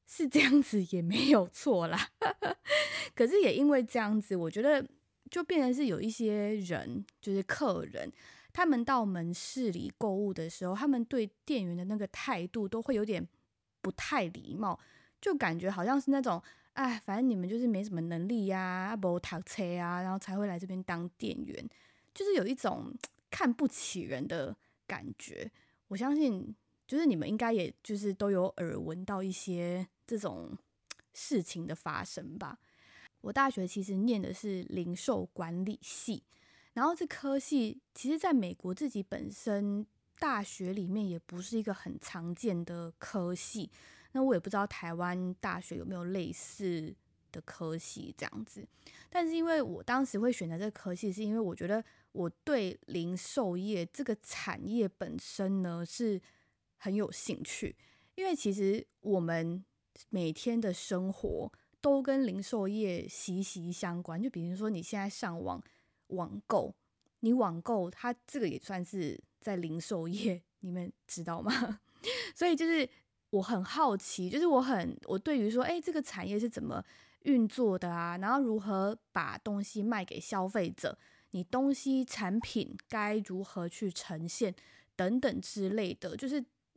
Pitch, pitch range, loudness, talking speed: 205 Hz, 185-255 Hz, -34 LUFS, 235 characters per minute